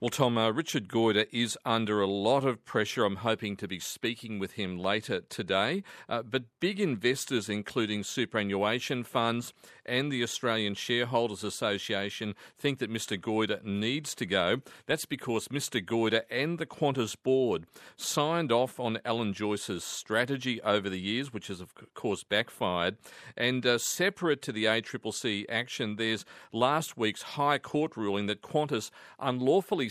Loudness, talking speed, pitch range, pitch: -30 LUFS, 155 wpm, 105-130 Hz, 115 Hz